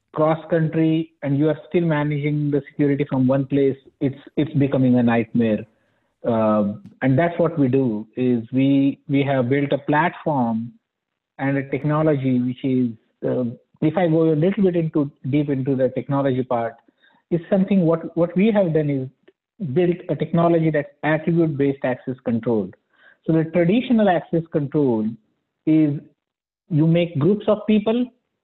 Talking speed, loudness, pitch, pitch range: 155 wpm, -21 LUFS, 150 Hz, 130-165 Hz